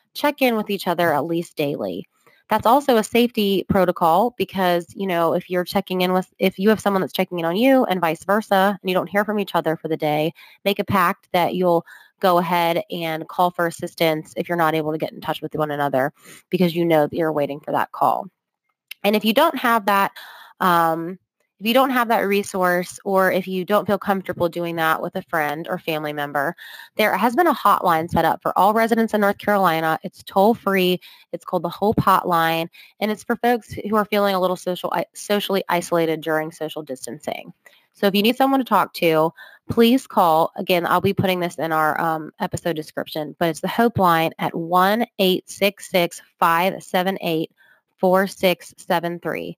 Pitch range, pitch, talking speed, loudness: 165-200 Hz, 180 Hz, 200 wpm, -20 LUFS